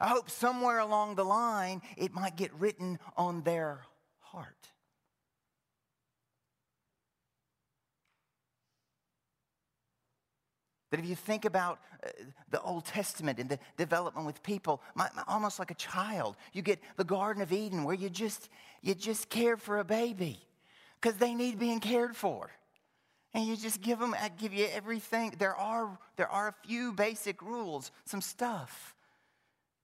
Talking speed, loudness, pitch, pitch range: 145 wpm, -34 LUFS, 200 Hz, 175-225 Hz